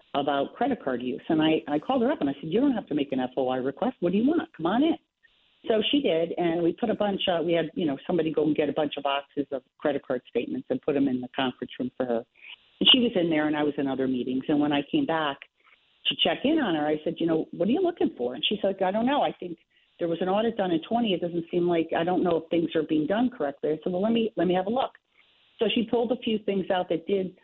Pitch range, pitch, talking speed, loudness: 145-215 Hz, 170 Hz, 300 wpm, -26 LUFS